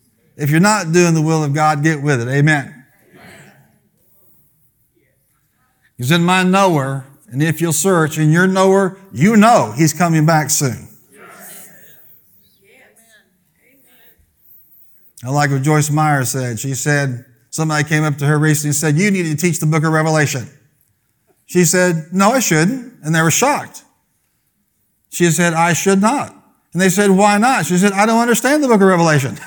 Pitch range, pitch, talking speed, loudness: 145-185 Hz, 160 Hz, 165 wpm, -14 LUFS